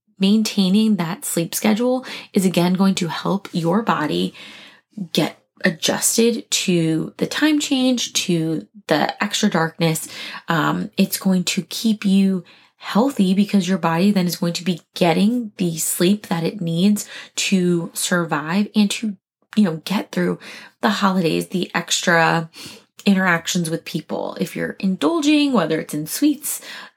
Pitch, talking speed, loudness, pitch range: 190 Hz, 140 wpm, -19 LUFS, 170-215 Hz